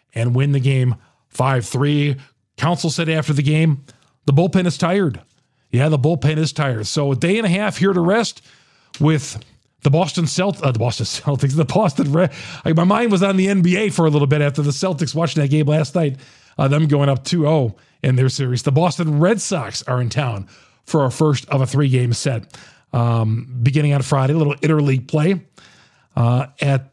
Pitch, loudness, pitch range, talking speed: 145 Hz, -18 LUFS, 130-165 Hz, 200 wpm